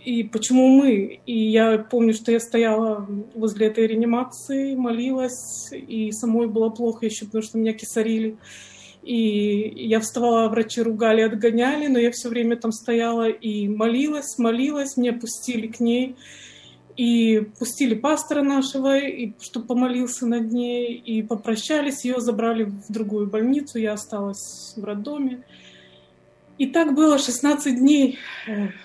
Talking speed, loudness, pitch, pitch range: 135 wpm, -22 LUFS, 235 Hz, 220-255 Hz